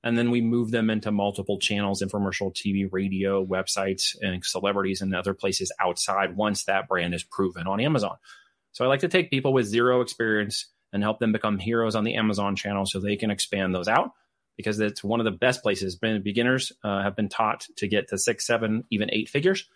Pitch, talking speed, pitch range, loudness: 105 Hz, 215 wpm, 100-115 Hz, -25 LUFS